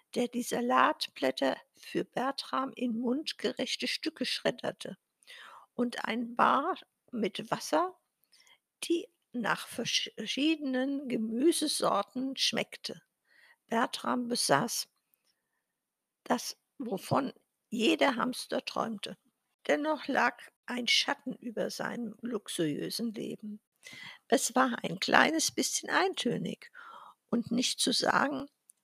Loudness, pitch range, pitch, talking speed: -31 LUFS, 235-300 Hz, 250 Hz, 90 wpm